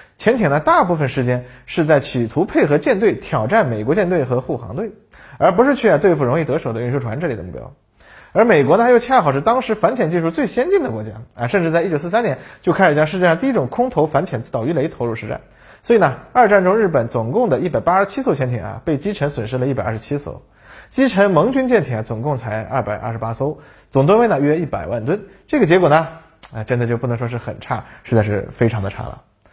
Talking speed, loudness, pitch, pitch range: 360 characters per minute, -17 LUFS, 145 Hz, 120-195 Hz